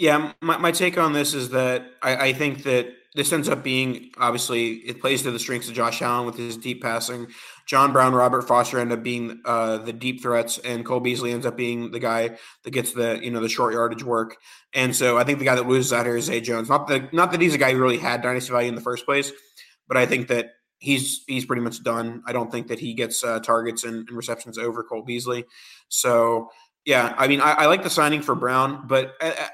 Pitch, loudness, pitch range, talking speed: 125 Hz, -22 LUFS, 115-130 Hz, 250 wpm